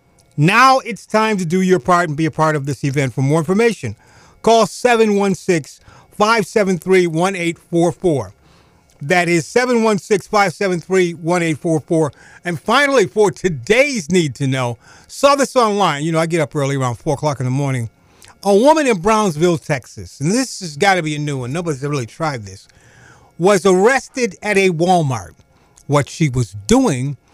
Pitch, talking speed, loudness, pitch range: 170 Hz, 165 wpm, -16 LUFS, 140-200 Hz